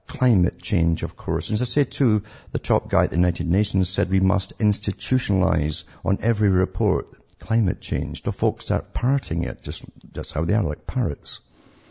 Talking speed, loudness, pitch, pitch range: 185 wpm, -23 LUFS, 100 Hz, 90-110 Hz